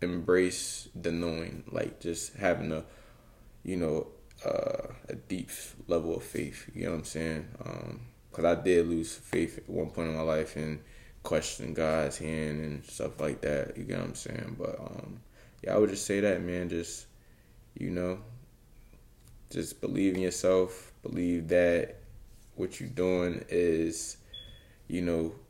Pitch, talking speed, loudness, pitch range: 85 Hz, 165 wpm, -32 LUFS, 80-100 Hz